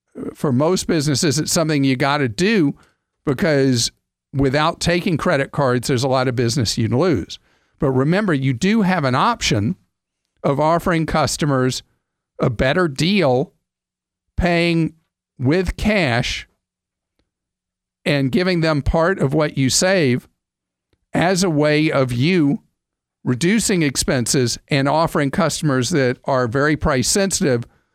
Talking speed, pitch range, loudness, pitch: 130 wpm, 130-170 Hz, -18 LUFS, 150 Hz